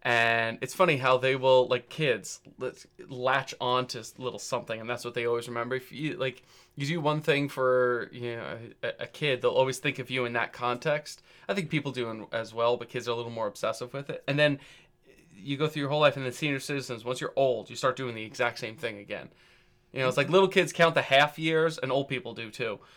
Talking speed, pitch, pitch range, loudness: 245 wpm, 130 Hz, 120-145 Hz, -28 LUFS